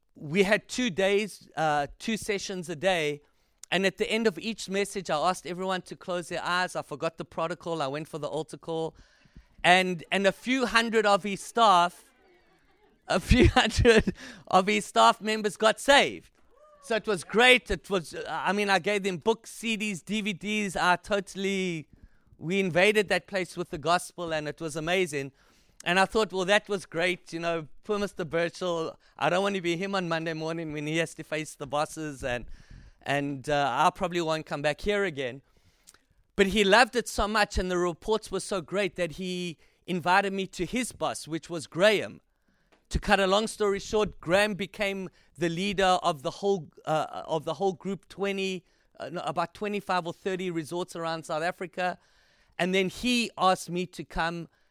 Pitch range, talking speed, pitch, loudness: 165-200 Hz, 190 wpm, 185 Hz, -27 LUFS